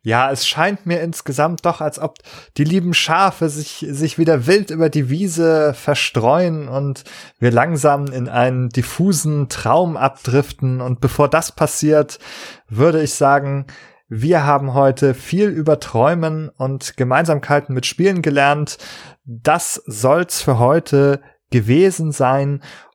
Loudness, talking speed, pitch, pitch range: -16 LUFS, 135 wpm, 145 Hz, 135-160 Hz